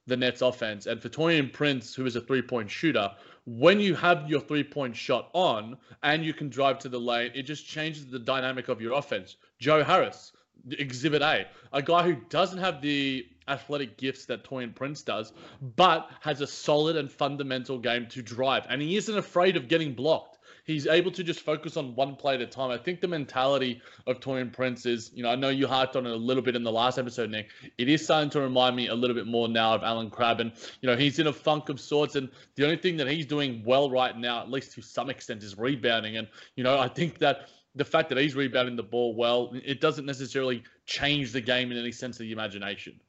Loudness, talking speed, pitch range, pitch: -28 LUFS, 235 wpm, 125-150 Hz, 135 Hz